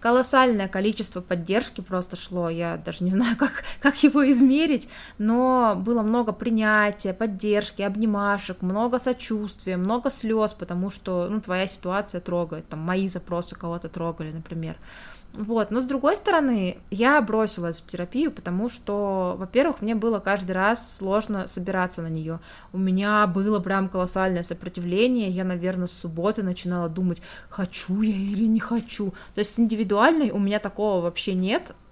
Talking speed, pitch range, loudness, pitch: 150 wpm, 180-225 Hz, -24 LUFS, 200 Hz